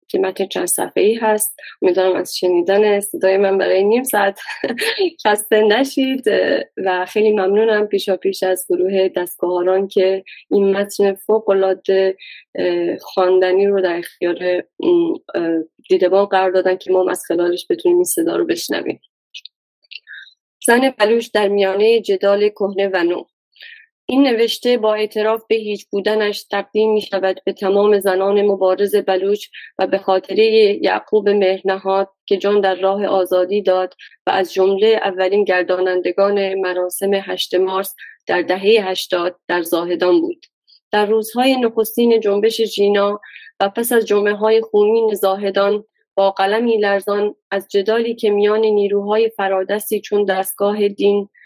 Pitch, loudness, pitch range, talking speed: 200 Hz, -17 LUFS, 190-215 Hz, 135 wpm